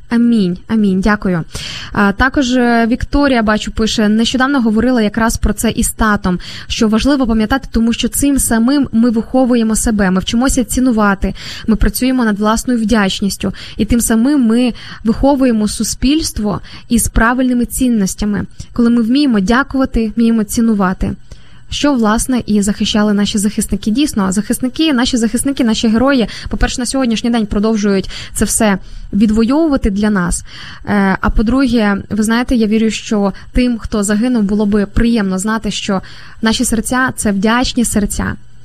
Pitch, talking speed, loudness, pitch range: 225 Hz, 140 wpm, -14 LUFS, 210-245 Hz